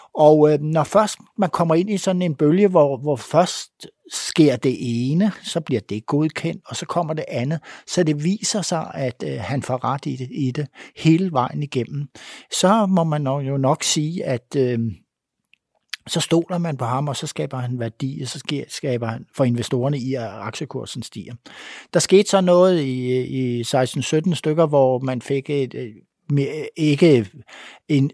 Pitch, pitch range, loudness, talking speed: 145 Hz, 130-165 Hz, -20 LUFS, 190 wpm